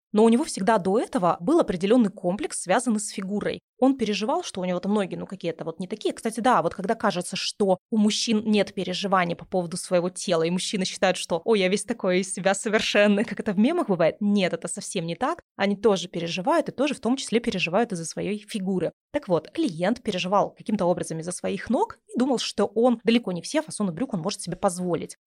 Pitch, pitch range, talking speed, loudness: 205 Hz, 185-230 Hz, 220 wpm, -25 LUFS